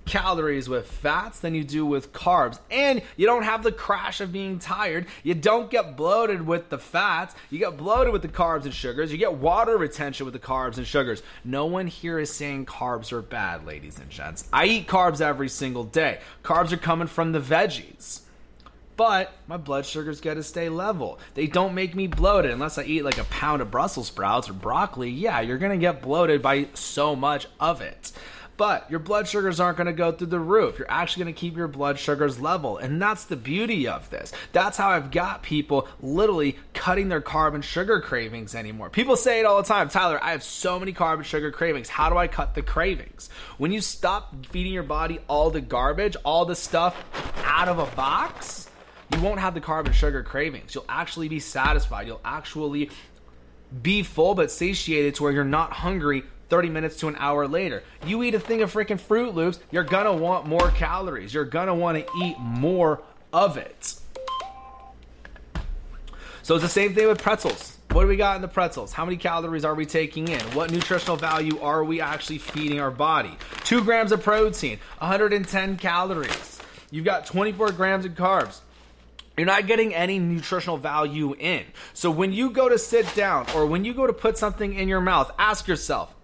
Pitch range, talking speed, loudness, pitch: 150-195 Hz, 200 wpm, -24 LUFS, 170 Hz